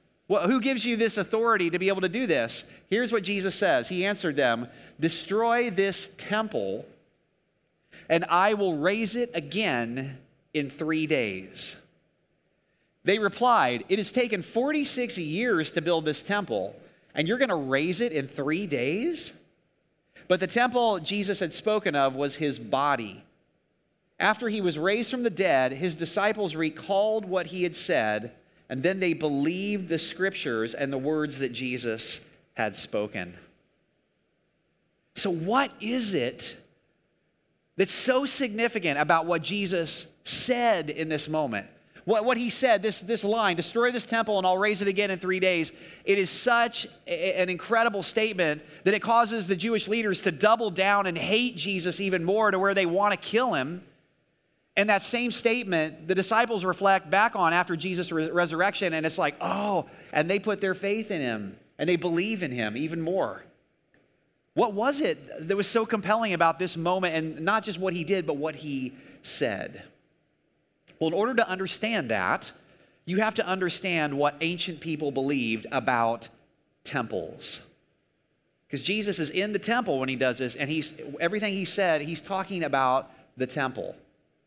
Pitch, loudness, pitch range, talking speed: 185 Hz, -27 LUFS, 160-215 Hz, 165 wpm